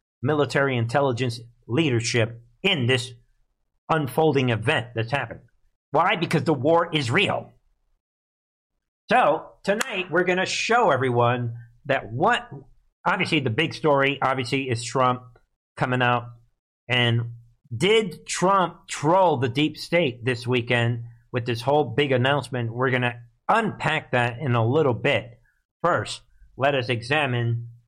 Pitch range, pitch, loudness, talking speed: 120-155 Hz, 130 Hz, -23 LUFS, 130 wpm